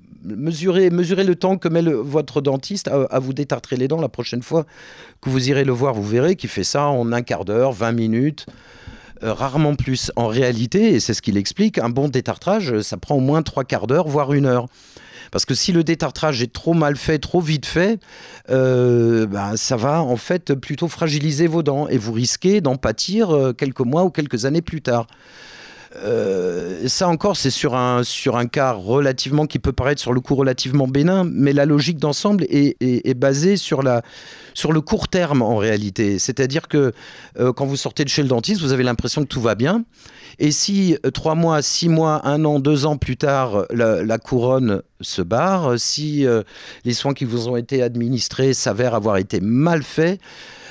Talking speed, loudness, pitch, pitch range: 205 wpm, -19 LUFS, 140 Hz, 125-160 Hz